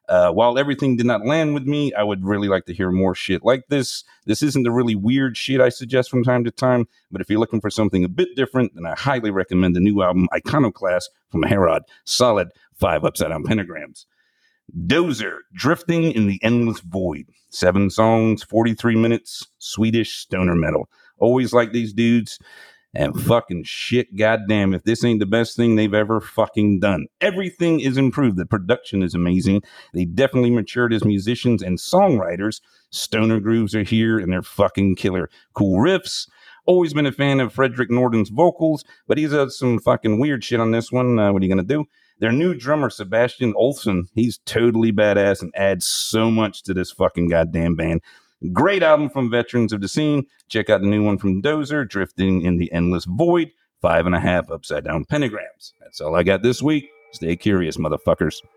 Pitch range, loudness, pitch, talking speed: 100-130 Hz, -19 LUFS, 115 Hz, 190 wpm